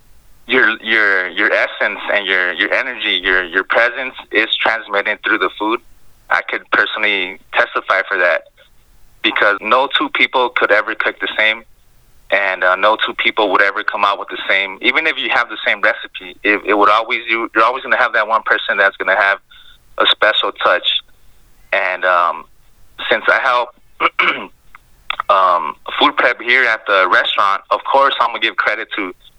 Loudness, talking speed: -14 LUFS, 180 wpm